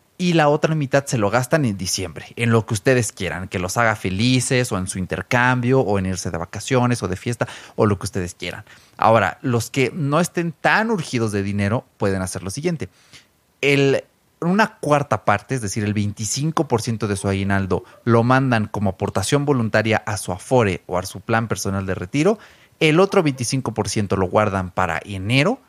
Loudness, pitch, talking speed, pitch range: -20 LUFS, 115 Hz, 190 wpm, 100-135 Hz